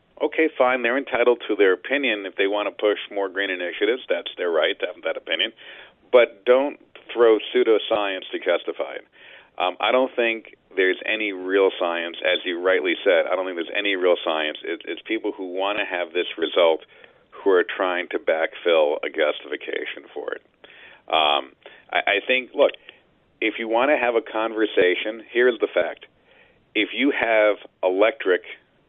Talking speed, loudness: 175 wpm, -22 LUFS